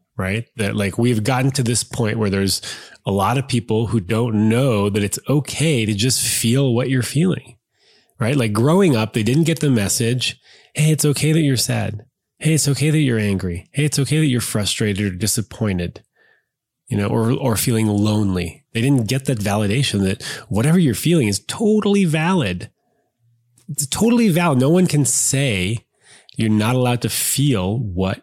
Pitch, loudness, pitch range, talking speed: 120 Hz, -18 LUFS, 105-140 Hz, 185 wpm